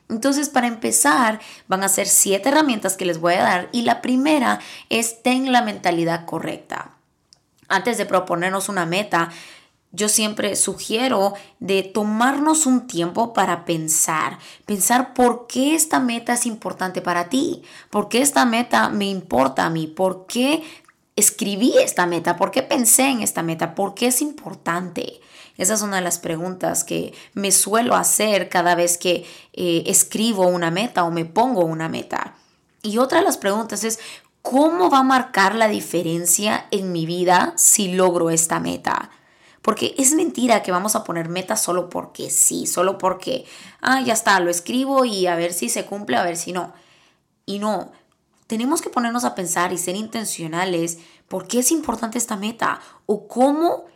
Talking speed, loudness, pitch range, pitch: 170 wpm, -19 LUFS, 180-245 Hz, 205 Hz